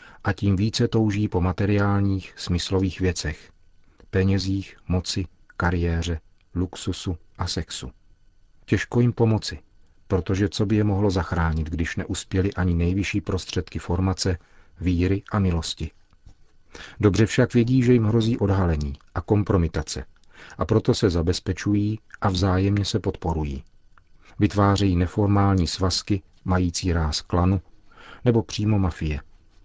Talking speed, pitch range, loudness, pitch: 115 wpm, 85-100 Hz, -24 LUFS, 95 Hz